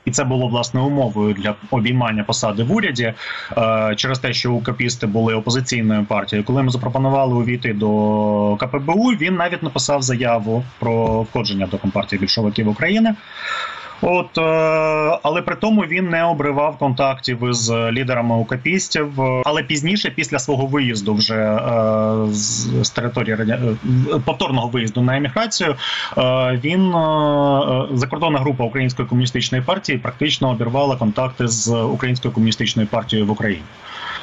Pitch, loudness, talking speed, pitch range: 125 Hz, -18 LUFS, 130 wpm, 115-145 Hz